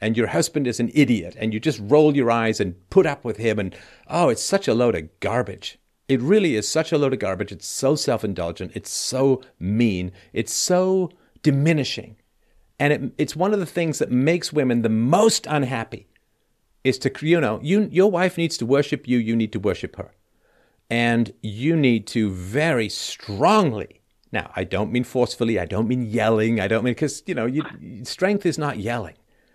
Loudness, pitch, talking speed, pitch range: -22 LUFS, 120 Hz, 200 wpm, 110-150 Hz